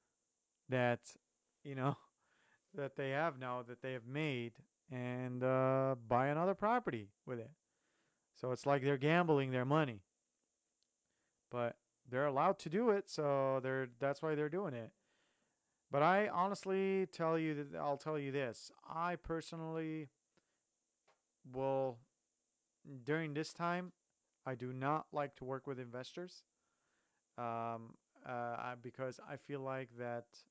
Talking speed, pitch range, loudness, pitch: 140 wpm, 125-155 Hz, -39 LUFS, 135 Hz